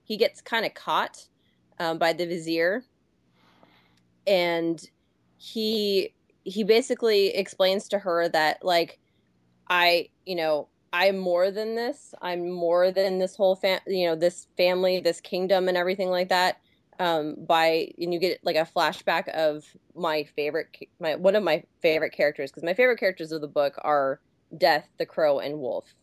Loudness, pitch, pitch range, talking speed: -25 LUFS, 175 Hz, 155-190 Hz, 165 wpm